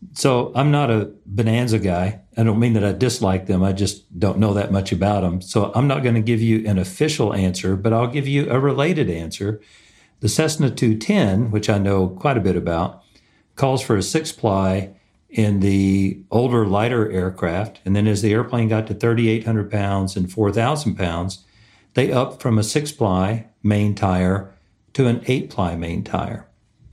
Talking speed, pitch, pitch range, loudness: 185 wpm, 105 Hz, 95-120 Hz, -20 LUFS